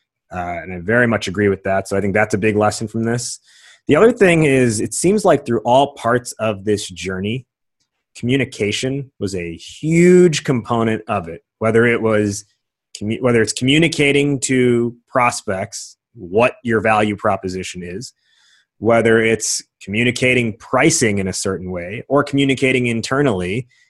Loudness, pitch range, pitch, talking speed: -17 LUFS, 105-130 Hz, 115 Hz, 155 wpm